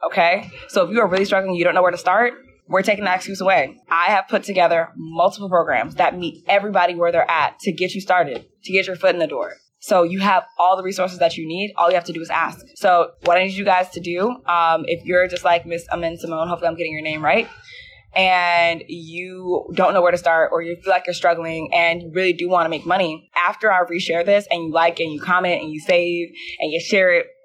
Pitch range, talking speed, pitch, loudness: 170-190 Hz, 255 wpm, 180 Hz, -19 LUFS